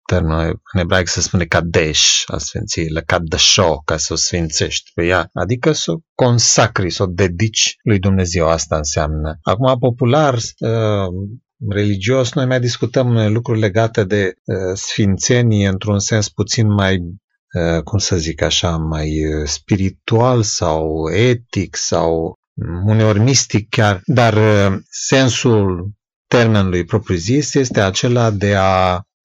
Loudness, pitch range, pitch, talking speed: -15 LUFS, 90-115 Hz, 100 Hz, 135 wpm